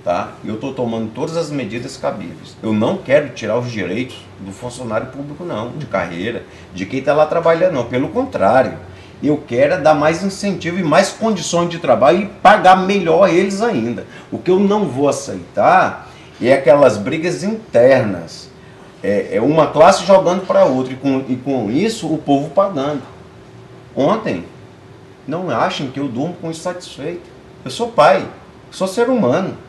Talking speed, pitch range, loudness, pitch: 160 wpm, 130-190 Hz, -16 LUFS, 160 Hz